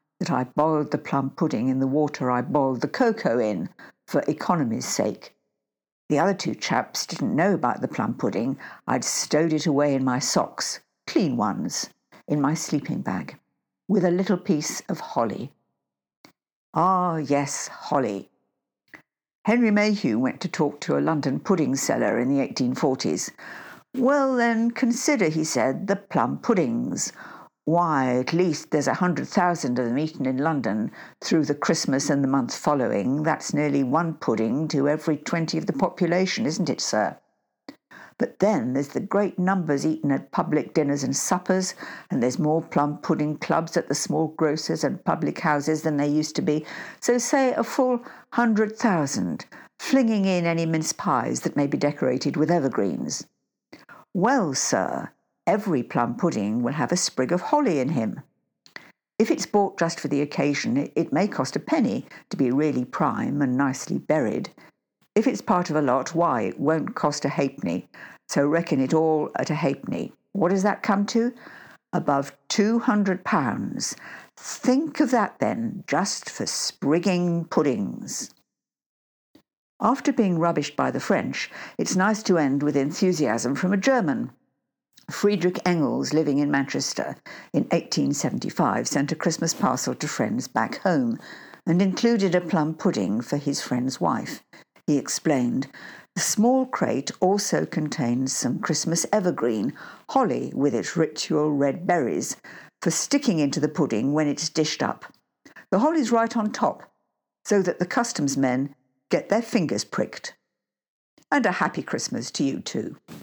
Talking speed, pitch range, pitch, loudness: 160 wpm, 145-210 Hz, 165 Hz, -24 LUFS